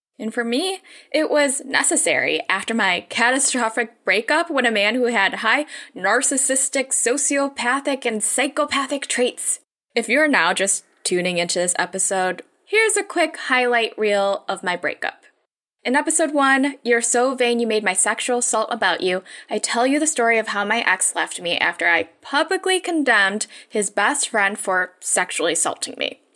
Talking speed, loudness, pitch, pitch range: 165 wpm, -19 LUFS, 240 Hz, 200-280 Hz